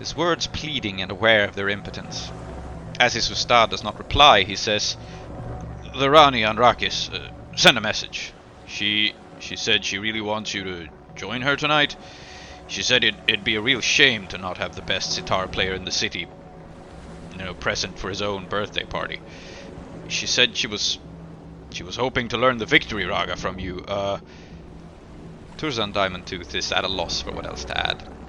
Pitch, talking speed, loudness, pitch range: 100 Hz, 185 wpm, -21 LUFS, 90-115 Hz